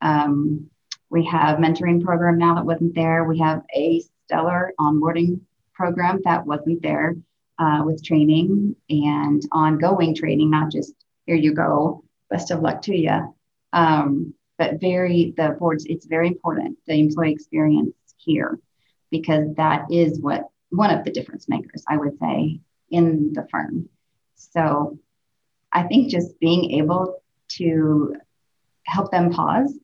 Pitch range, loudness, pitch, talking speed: 150-170 Hz, -21 LUFS, 165 Hz, 145 wpm